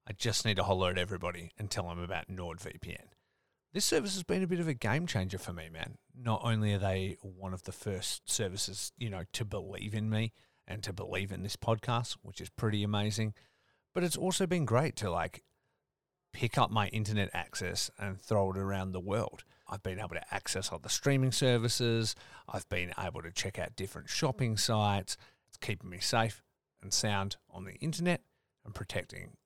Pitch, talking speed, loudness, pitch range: 105 Hz, 200 wpm, -34 LUFS, 95-120 Hz